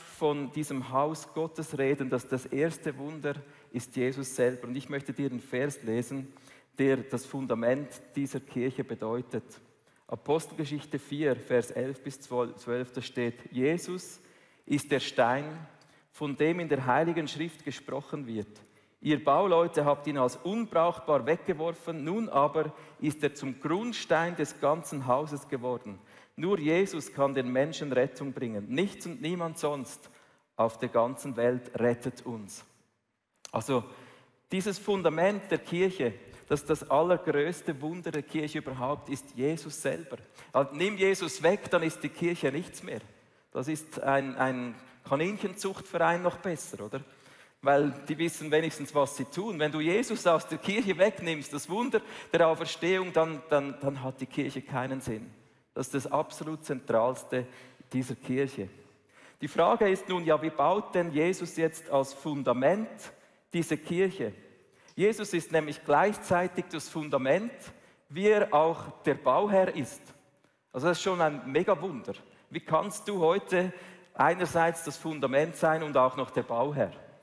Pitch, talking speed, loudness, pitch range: 145 Hz, 150 wpm, -30 LUFS, 135-165 Hz